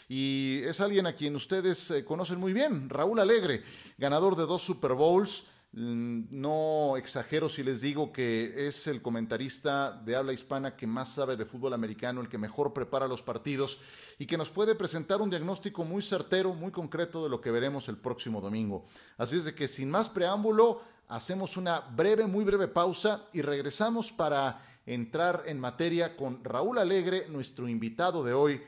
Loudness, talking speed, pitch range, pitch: -31 LUFS, 175 wpm, 130-185 Hz, 150 Hz